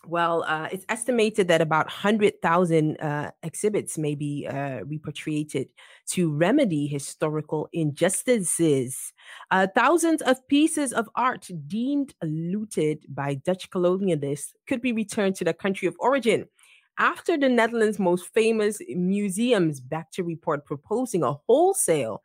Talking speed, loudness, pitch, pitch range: 130 wpm, -25 LUFS, 180 Hz, 155-225 Hz